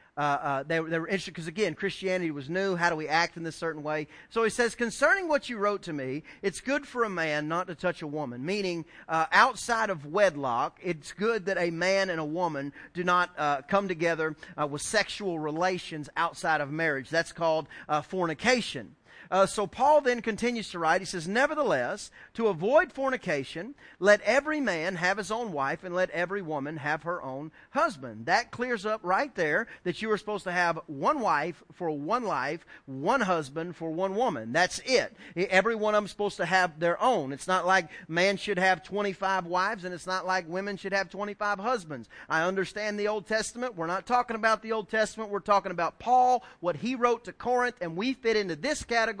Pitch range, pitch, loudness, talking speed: 165-220 Hz, 185 Hz, -28 LUFS, 210 wpm